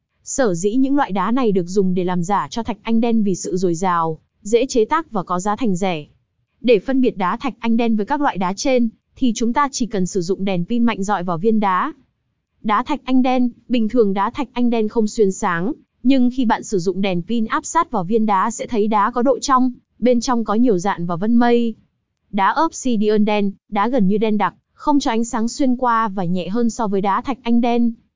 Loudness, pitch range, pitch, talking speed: -19 LUFS, 195-245 Hz, 225 Hz, 245 wpm